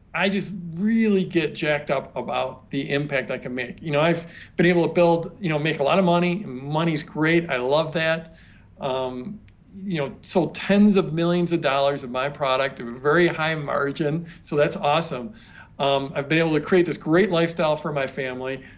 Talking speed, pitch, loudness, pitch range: 200 wpm, 160 Hz, -23 LUFS, 140-175 Hz